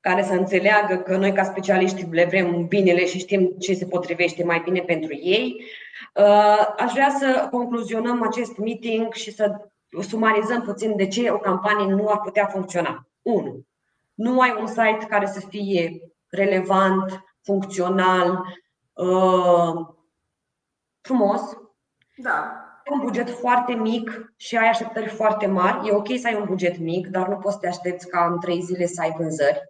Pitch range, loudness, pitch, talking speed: 180-220 Hz, -21 LUFS, 195 Hz, 160 wpm